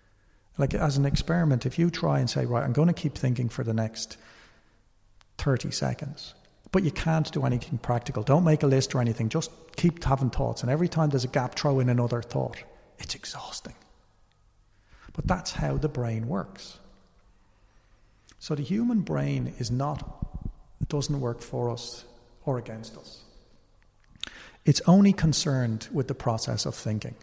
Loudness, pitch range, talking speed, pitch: -27 LUFS, 110-150 Hz, 165 wpm, 125 Hz